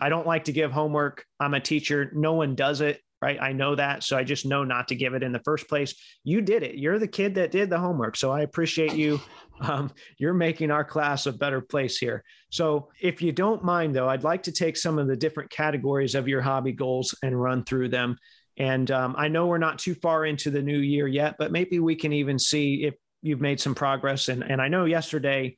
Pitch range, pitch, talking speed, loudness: 135-160 Hz, 145 Hz, 245 wpm, -26 LUFS